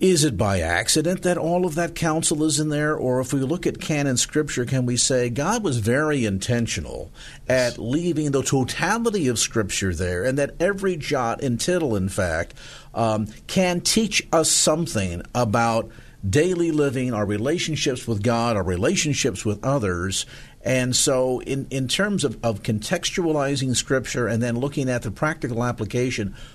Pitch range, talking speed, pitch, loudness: 115-155 Hz, 165 wpm, 130 Hz, -22 LUFS